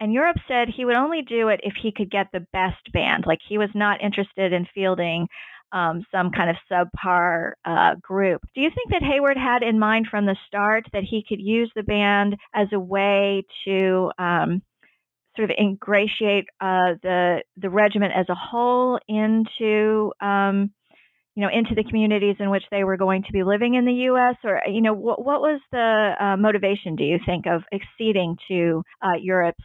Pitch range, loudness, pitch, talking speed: 185-220 Hz, -22 LUFS, 200 Hz, 195 wpm